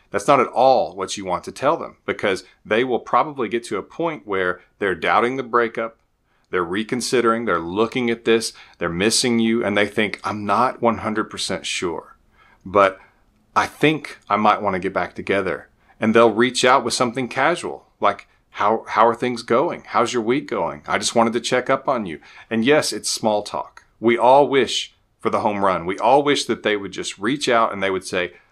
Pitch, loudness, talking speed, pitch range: 115 Hz, -20 LUFS, 210 wpm, 105-120 Hz